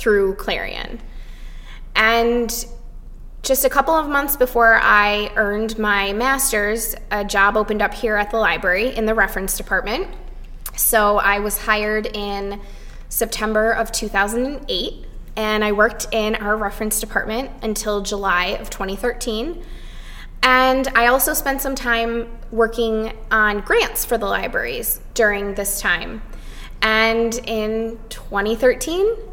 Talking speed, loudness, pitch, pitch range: 125 wpm, -19 LUFS, 220 Hz, 205-240 Hz